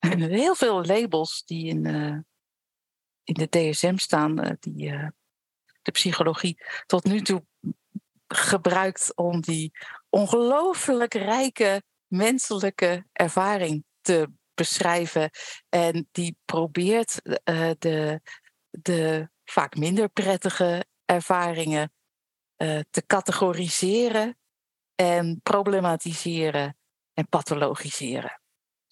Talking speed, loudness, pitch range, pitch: 95 wpm, -25 LUFS, 160-195 Hz, 175 Hz